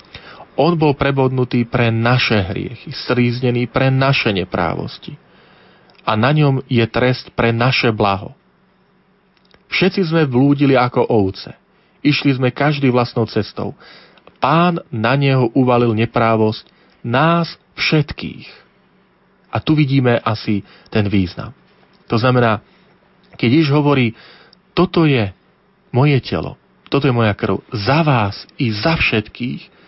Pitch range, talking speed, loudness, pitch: 115-150 Hz, 120 wpm, -16 LUFS, 130 Hz